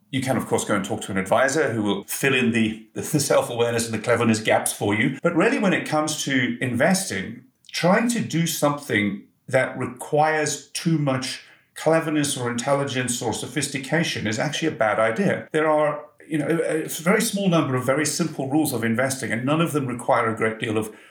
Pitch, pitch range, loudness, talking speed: 140 Hz, 120-155 Hz, -22 LUFS, 200 wpm